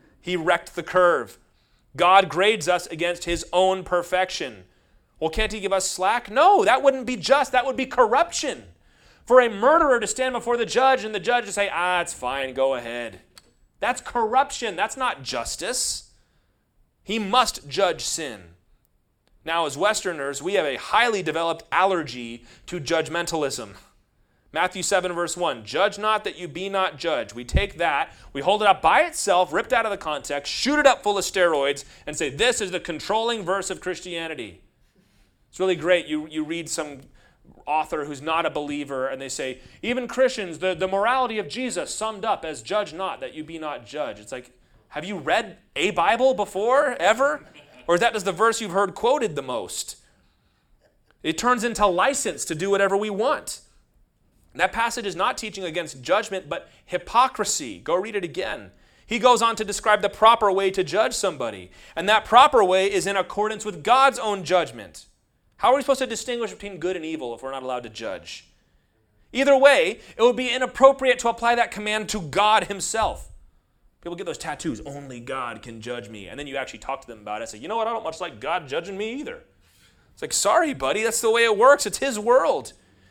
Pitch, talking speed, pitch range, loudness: 195 Hz, 195 wpm, 160-235 Hz, -22 LUFS